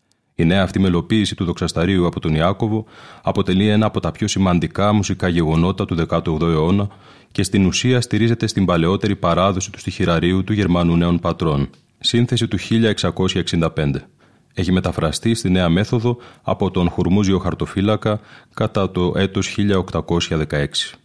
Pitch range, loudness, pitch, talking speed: 85-105 Hz, -18 LUFS, 95 Hz, 135 wpm